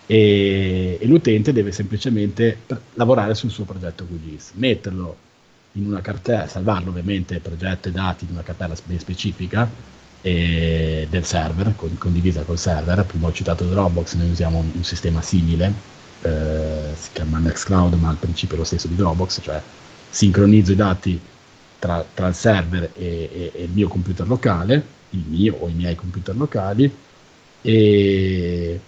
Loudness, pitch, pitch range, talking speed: -20 LUFS, 90 Hz, 85-105 Hz, 160 wpm